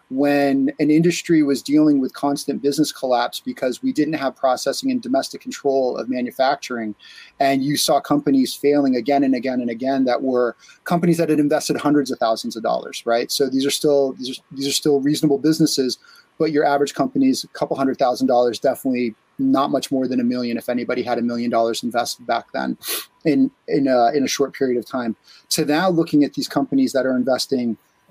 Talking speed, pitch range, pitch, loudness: 205 wpm, 125-150 Hz, 135 Hz, -20 LUFS